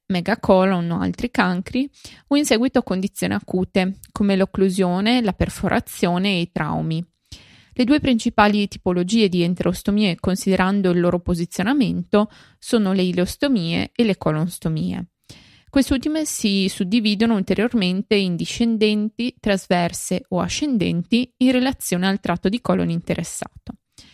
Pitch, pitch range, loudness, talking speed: 200 Hz, 180-235 Hz, -20 LUFS, 120 wpm